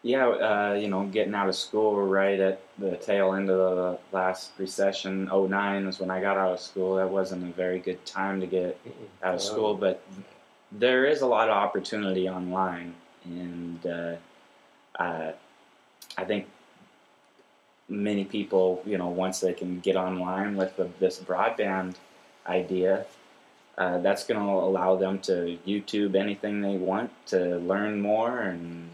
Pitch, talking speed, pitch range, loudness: 95 Hz, 165 wpm, 90-100 Hz, -28 LUFS